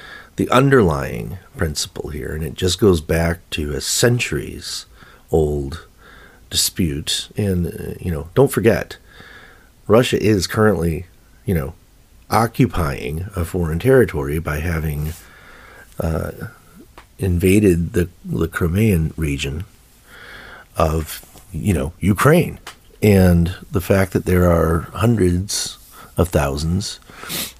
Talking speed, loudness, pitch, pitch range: 105 wpm, -19 LUFS, 90 Hz, 80-100 Hz